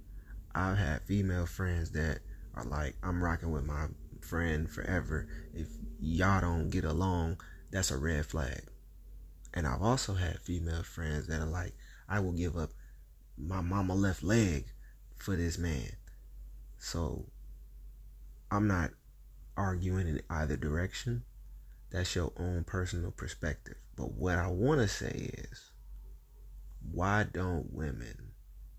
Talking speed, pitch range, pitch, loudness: 135 wpm, 75-95 Hz, 85 Hz, -35 LUFS